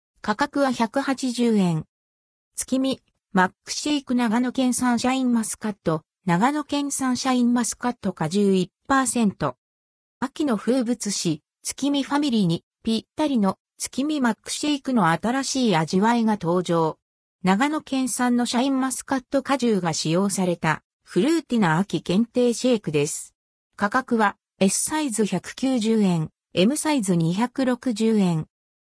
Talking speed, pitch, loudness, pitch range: 265 characters per minute, 230 Hz, -23 LUFS, 185-260 Hz